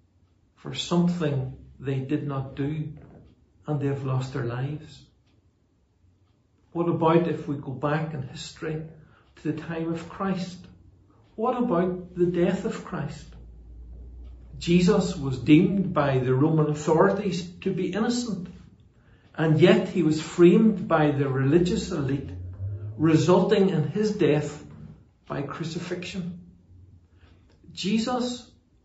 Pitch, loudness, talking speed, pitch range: 150 Hz, -25 LUFS, 120 wpm, 115-175 Hz